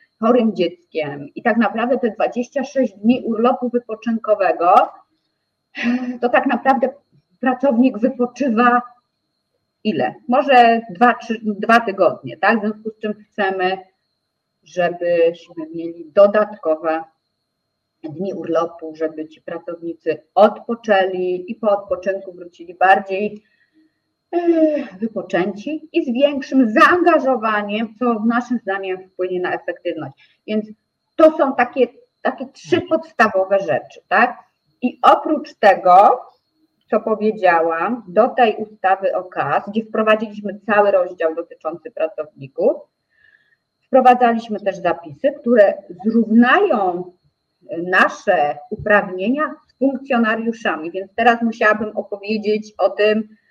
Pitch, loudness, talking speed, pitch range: 215 Hz, -17 LUFS, 105 wpm, 185-250 Hz